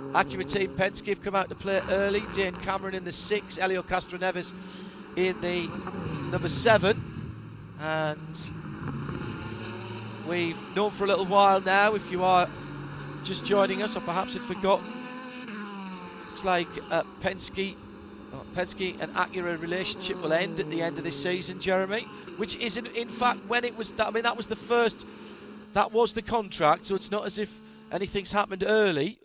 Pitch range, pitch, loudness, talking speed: 180-210 Hz, 190 Hz, -28 LUFS, 170 wpm